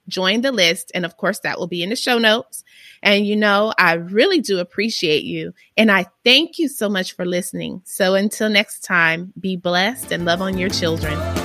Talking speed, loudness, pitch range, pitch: 210 wpm, -18 LUFS, 180-220 Hz, 190 Hz